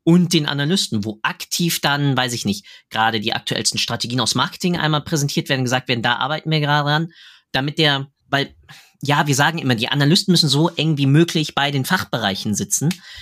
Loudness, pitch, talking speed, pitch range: -18 LUFS, 145 Hz, 195 wpm, 125-165 Hz